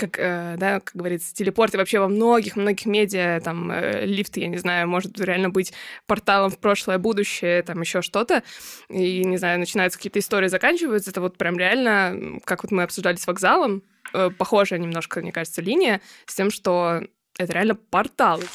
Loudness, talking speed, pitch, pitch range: -22 LUFS, 175 wpm, 190 Hz, 180-205 Hz